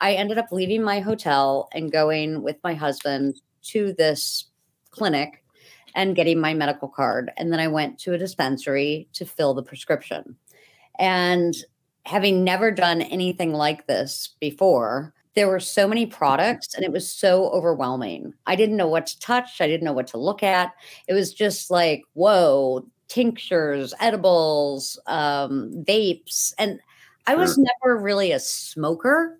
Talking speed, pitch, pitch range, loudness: 155 wpm, 170 Hz, 145-195 Hz, -22 LUFS